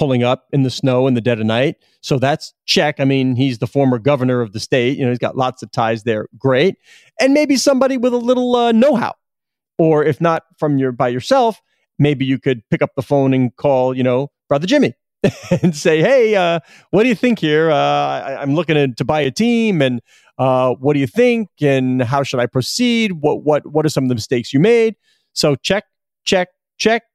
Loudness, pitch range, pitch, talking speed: -16 LUFS, 130-190 Hz, 145 Hz, 225 wpm